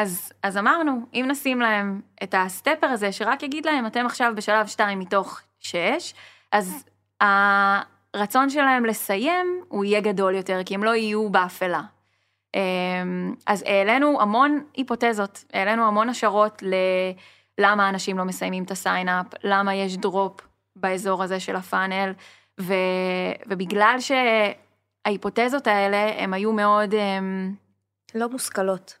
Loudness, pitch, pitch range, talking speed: -23 LUFS, 200 Hz, 190-225 Hz, 120 wpm